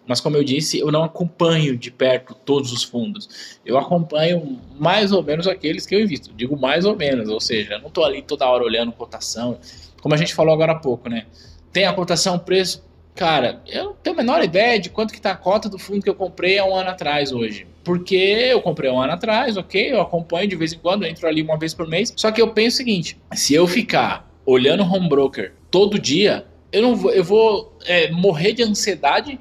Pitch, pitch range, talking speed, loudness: 170 Hz, 135-195 Hz, 235 wpm, -19 LUFS